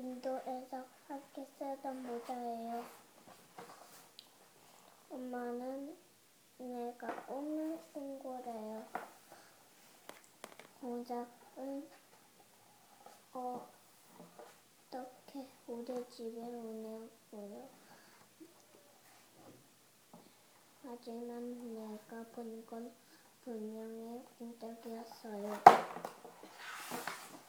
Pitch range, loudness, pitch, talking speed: 230-260 Hz, -40 LUFS, 245 Hz, 115 characters per minute